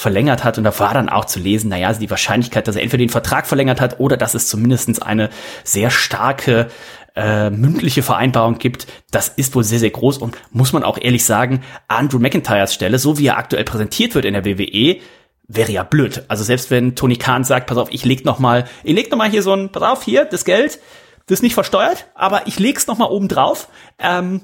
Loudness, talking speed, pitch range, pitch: -16 LUFS, 230 wpm, 115-145 Hz, 125 Hz